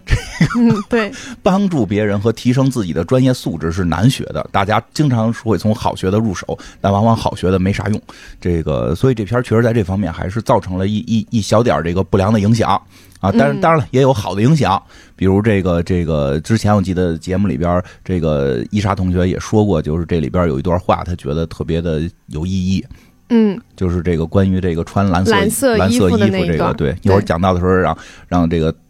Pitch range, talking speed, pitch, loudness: 90-115 Hz, 320 characters per minute, 95 Hz, -16 LUFS